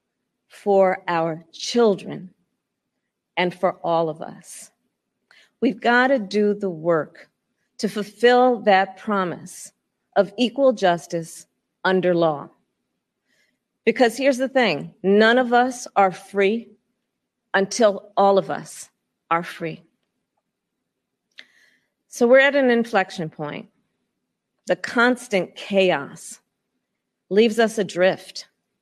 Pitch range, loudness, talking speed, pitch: 185-235 Hz, -20 LUFS, 105 wpm, 200 Hz